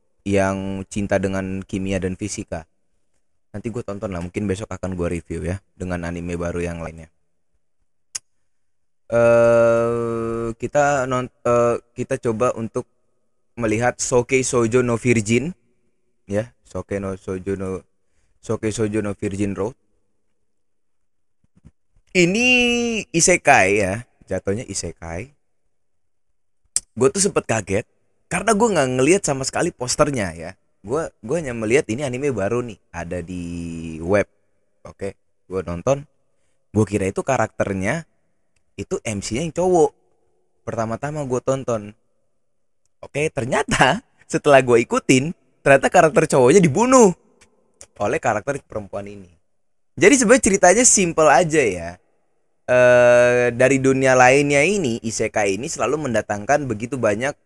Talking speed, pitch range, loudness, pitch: 120 wpm, 95-130 Hz, -19 LUFS, 110 Hz